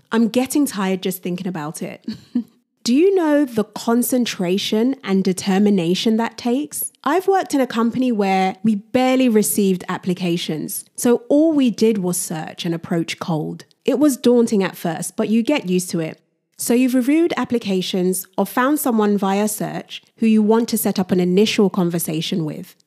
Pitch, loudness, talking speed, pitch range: 210 Hz, -19 LUFS, 170 wpm, 185-245 Hz